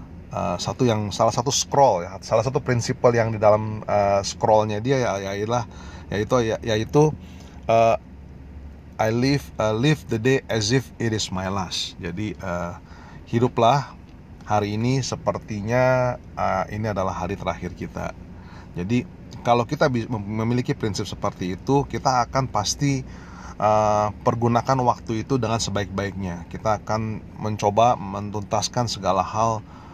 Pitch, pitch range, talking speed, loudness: 105 Hz, 90-120 Hz, 130 wpm, -23 LUFS